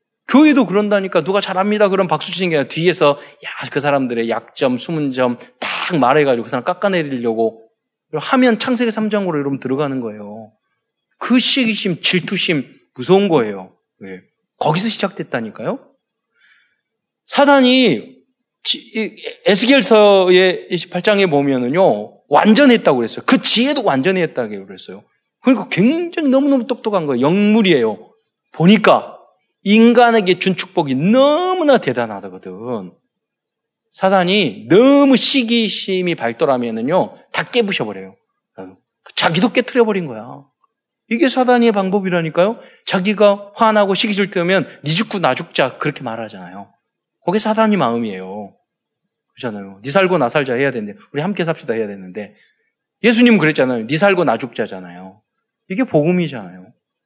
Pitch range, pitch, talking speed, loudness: 140-230 Hz, 190 Hz, 320 characters per minute, -15 LUFS